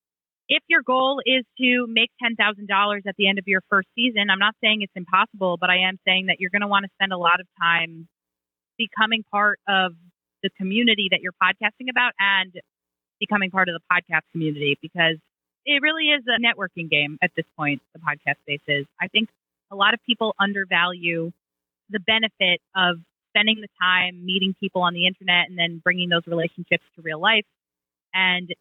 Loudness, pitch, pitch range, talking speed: -21 LUFS, 185 Hz, 170-210 Hz, 190 wpm